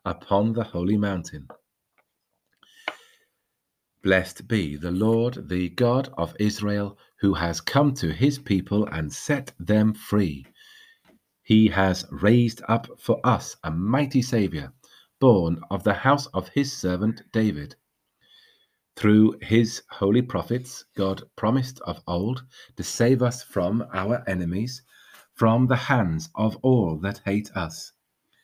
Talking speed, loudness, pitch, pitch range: 130 wpm, -24 LUFS, 105 Hz, 95-120 Hz